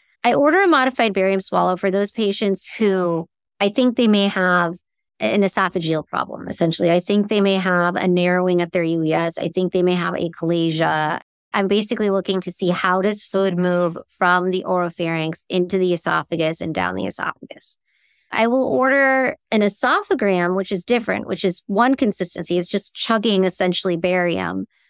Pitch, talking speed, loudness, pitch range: 185 Hz, 170 wpm, -19 LUFS, 175-205 Hz